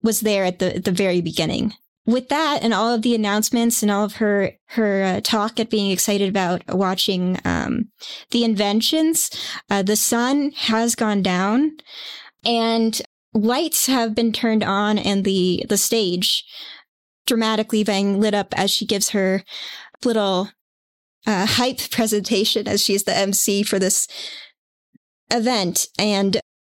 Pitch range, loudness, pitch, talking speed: 195-230 Hz, -20 LUFS, 215 Hz, 150 wpm